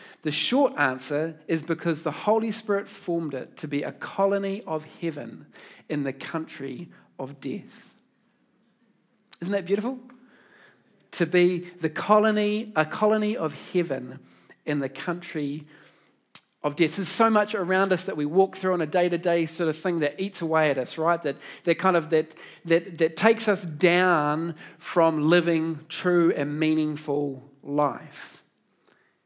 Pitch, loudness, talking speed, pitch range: 170 Hz, -25 LUFS, 150 wpm, 155-195 Hz